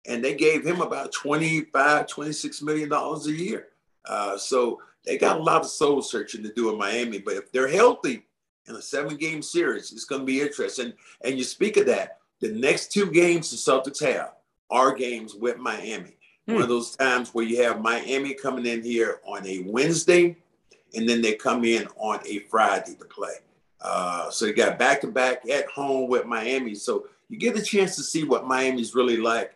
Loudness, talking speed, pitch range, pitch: -24 LUFS, 200 wpm, 120-160 Hz, 135 Hz